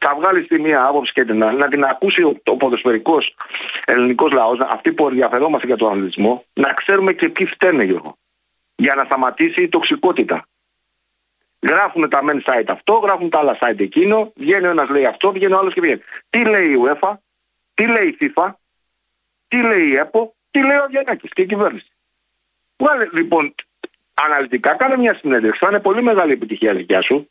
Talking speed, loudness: 180 wpm, -16 LUFS